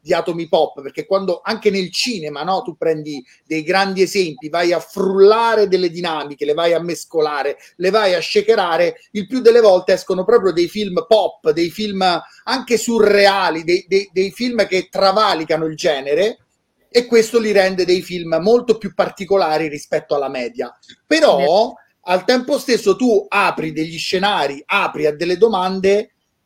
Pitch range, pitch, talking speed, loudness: 170-215 Hz, 190 Hz, 165 wpm, -16 LUFS